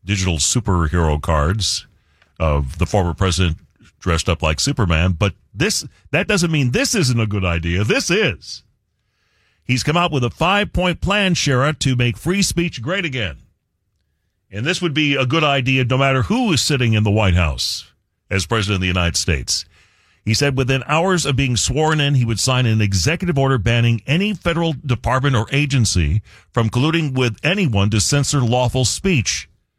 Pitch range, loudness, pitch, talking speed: 95-145 Hz, -18 LUFS, 120 Hz, 175 wpm